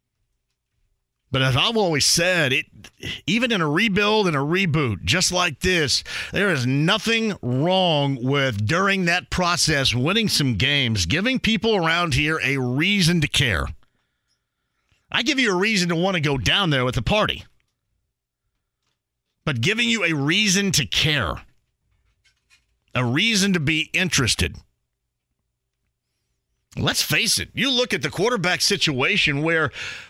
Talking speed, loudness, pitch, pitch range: 140 wpm, -20 LUFS, 160 Hz, 130-195 Hz